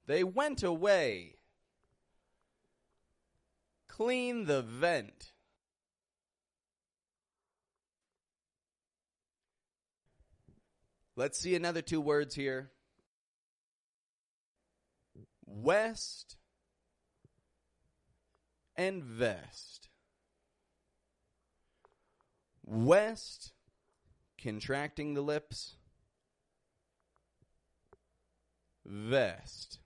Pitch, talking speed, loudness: 140 Hz, 40 wpm, -34 LUFS